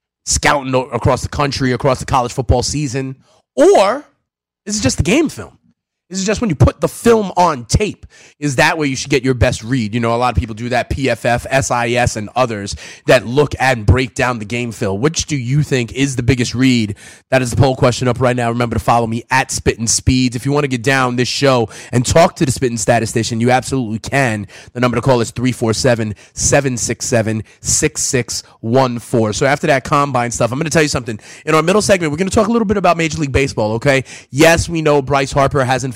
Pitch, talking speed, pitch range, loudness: 130 Hz, 230 wpm, 120-140 Hz, -15 LUFS